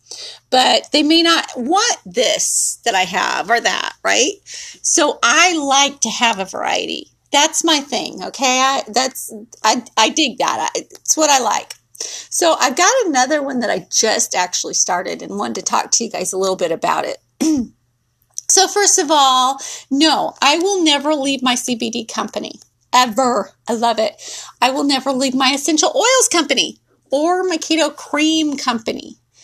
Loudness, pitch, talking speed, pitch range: -15 LUFS, 270 Hz, 170 wpm, 235-310 Hz